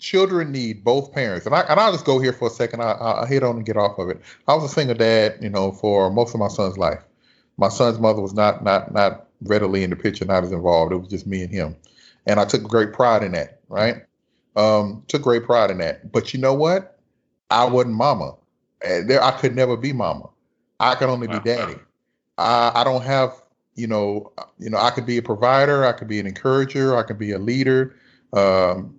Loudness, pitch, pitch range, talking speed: -20 LUFS, 120 Hz, 105-130 Hz, 230 wpm